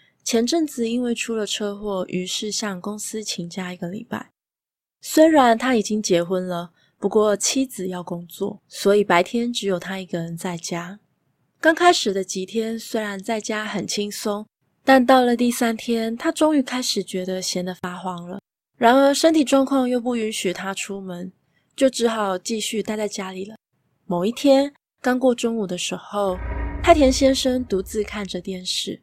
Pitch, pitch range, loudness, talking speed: 210 Hz, 185-245 Hz, -21 LUFS, 250 characters per minute